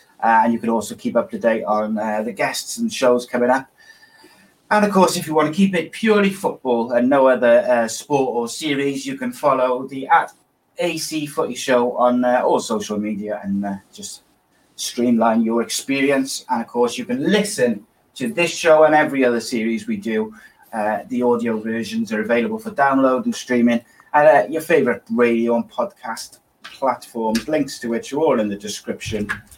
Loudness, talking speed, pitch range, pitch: -19 LUFS, 195 wpm, 115-155 Hz, 125 Hz